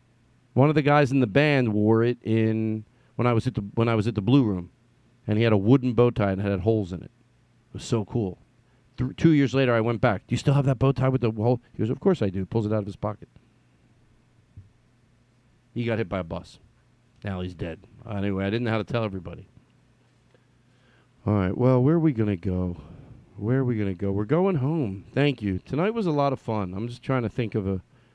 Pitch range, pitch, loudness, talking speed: 105-125 Hz, 120 Hz, -25 LUFS, 250 wpm